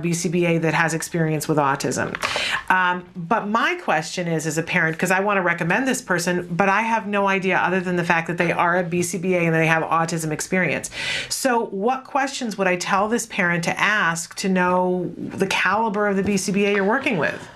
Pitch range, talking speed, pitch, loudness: 170-205 Hz, 205 wpm, 180 Hz, -21 LUFS